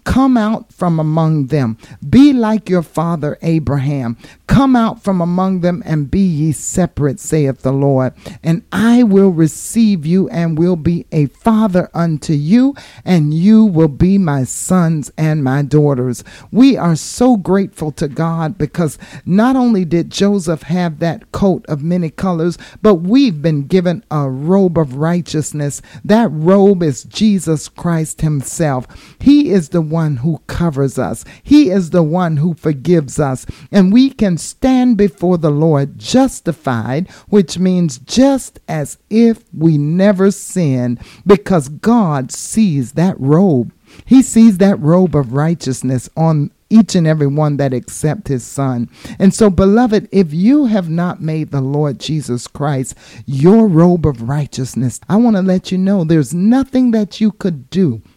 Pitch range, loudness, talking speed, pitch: 145-195 Hz, -13 LUFS, 155 wpm, 170 Hz